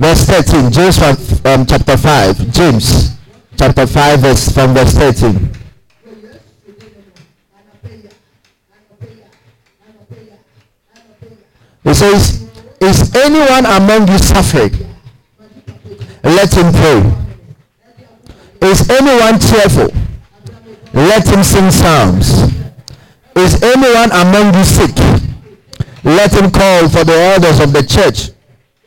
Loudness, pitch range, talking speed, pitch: -8 LUFS, 115-190 Hz, 90 wpm, 145 Hz